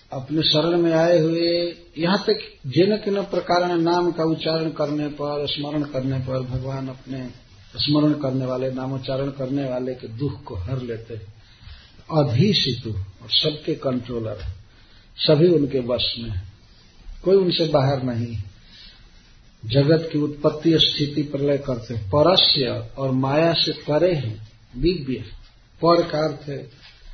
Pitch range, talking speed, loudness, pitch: 120-160 Hz, 130 wpm, -21 LUFS, 140 Hz